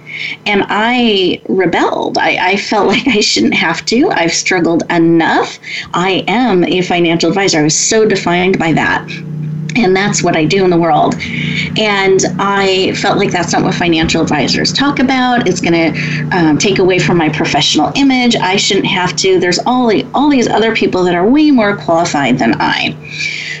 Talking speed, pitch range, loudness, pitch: 185 wpm, 165-210 Hz, -11 LUFS, 185 Hz